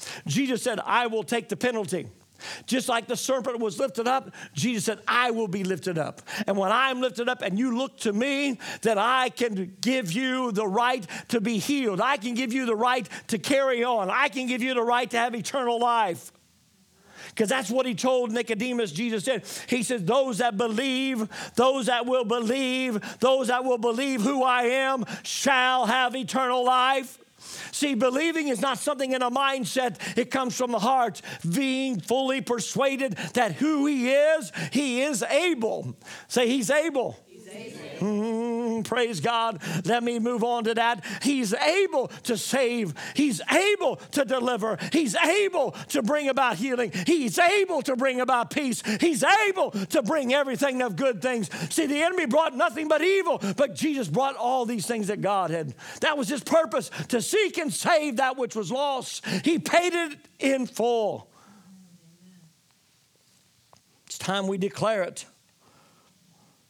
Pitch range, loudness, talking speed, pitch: 225-270 Hz, -25 LUFS, 170 wpm, 250 Hz